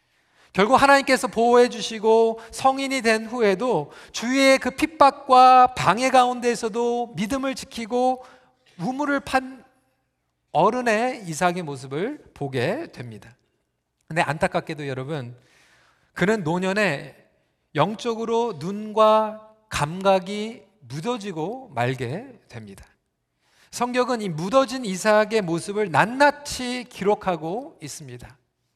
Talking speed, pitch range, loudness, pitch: 245 characters per minute, 160-250 Hz, -22 LUFS, 215 Hz